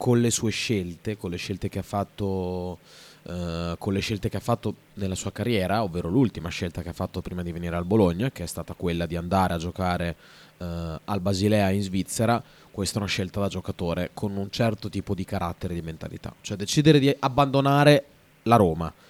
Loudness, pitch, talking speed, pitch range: -26 LUFS, 95 Hz, 205 wpm, 90-110 Hz